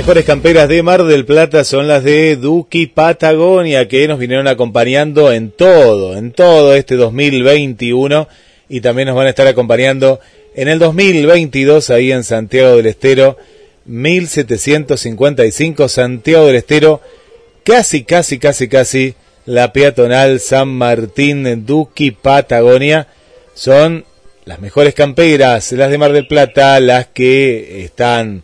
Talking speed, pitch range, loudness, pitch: 135 wpm, 125-155 Hz, -9 LUFS, 140 Hz